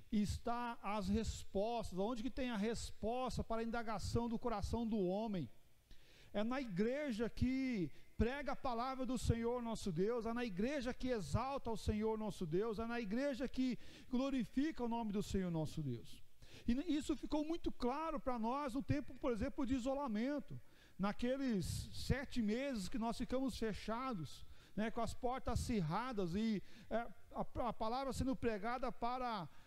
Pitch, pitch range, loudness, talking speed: 235 Hz, 210-255 Hz, -42 LUFS, 160 wpm